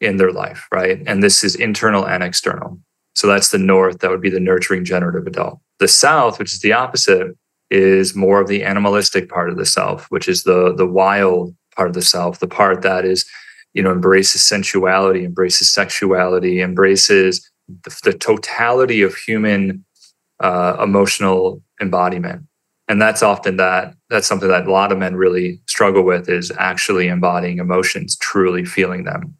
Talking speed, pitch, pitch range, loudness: 175 wpm, 95 Hz, 90-95 Hz, -15 LUFS